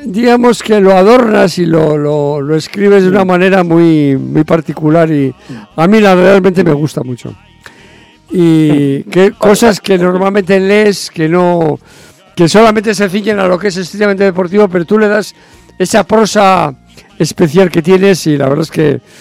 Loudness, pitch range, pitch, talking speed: -9 LUFS, 160-205 Hz, 185 Hz, 170 wpm